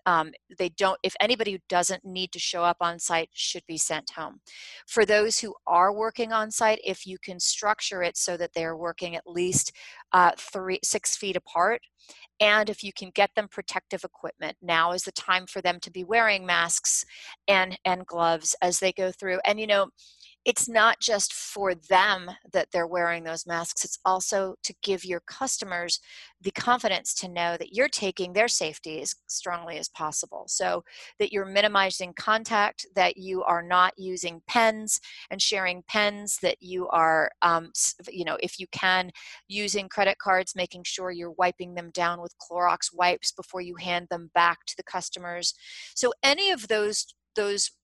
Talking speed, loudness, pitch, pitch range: 180 wpm, -26 LUFS, 185 Hz, 175-205 Hz